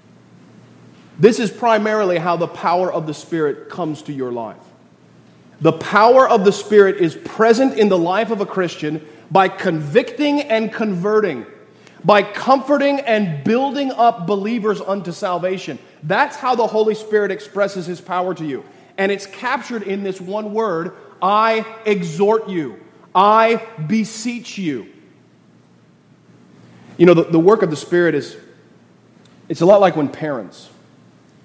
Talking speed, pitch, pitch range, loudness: 145 wpm, 200 Hz, 170-220 Hz, -17 LUFS